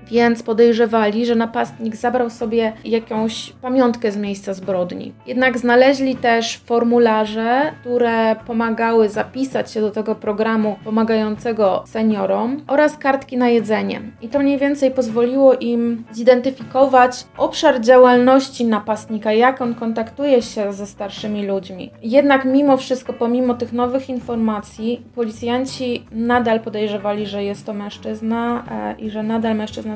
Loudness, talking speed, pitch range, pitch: -18 LUFS, 125 wpm, 220-250 Hz, 235 Hz